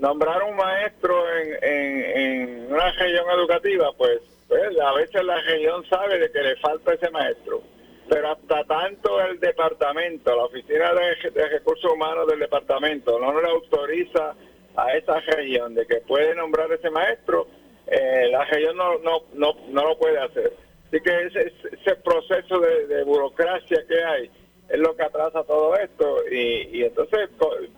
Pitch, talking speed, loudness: 235 Hz, 165 wpm, -22 LUFS